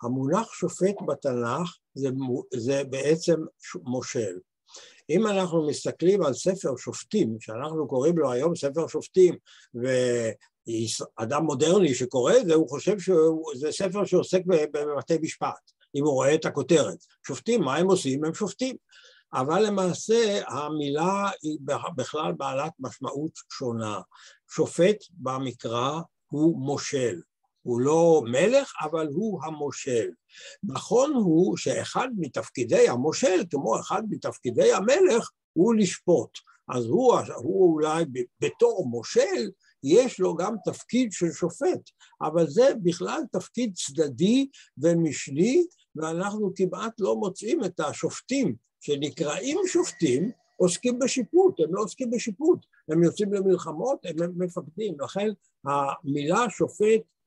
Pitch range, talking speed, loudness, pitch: 150-215 Hz, 115 wpm, -26 LUFS, 170 Hz